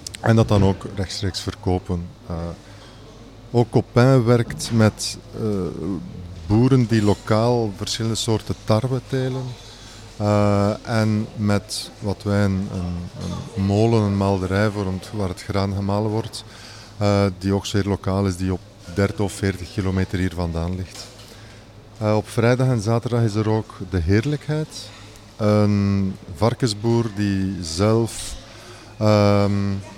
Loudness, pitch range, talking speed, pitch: -21 LUFS, 100-115 Hz, 130 wpm, 105 Hz